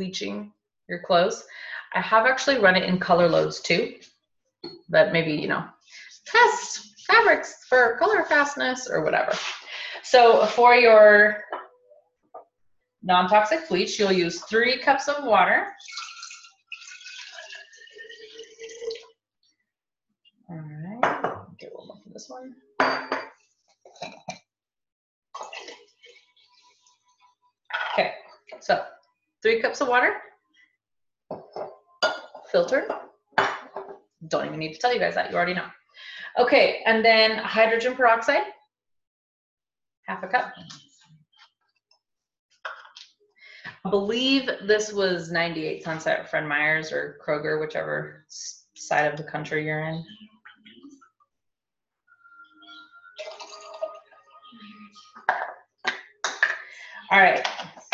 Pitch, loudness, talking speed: 250 Hz, -22 LUFS, 85 wpm